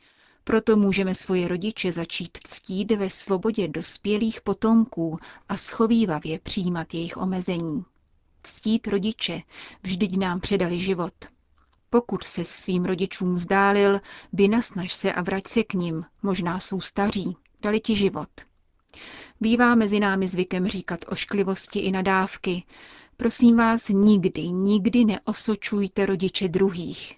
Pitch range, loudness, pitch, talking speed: 180-215 Hz, -24 LUFS, 195 Hz, 120 wpm